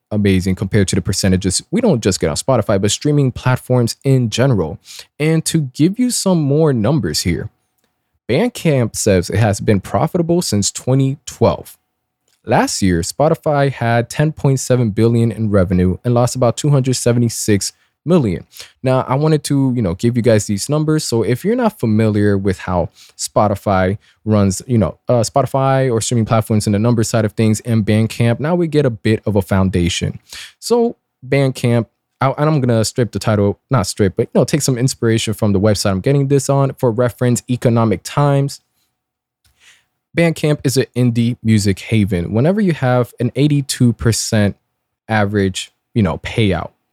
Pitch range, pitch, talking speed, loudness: 105-140 Hz, 120 Hz, 170 wpm, -16 LUFS